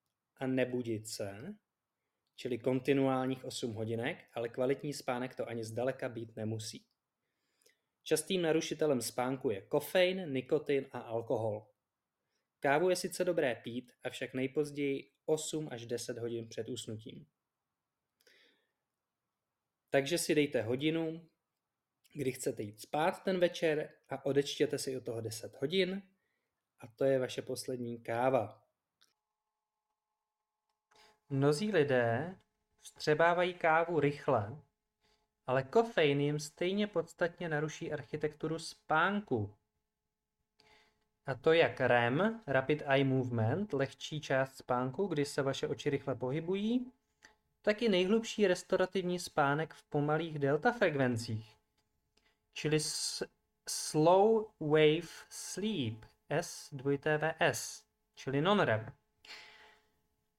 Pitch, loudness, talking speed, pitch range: 145 Hz, -34 LUFS, 105 wpm, 125-170 Hz